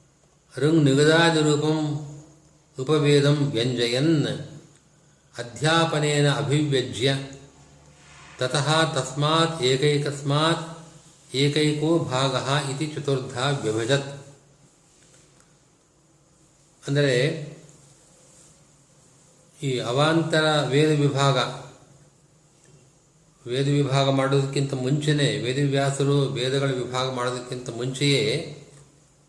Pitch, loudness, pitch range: 145 Hz, -23 LUFS, 135-155 Hz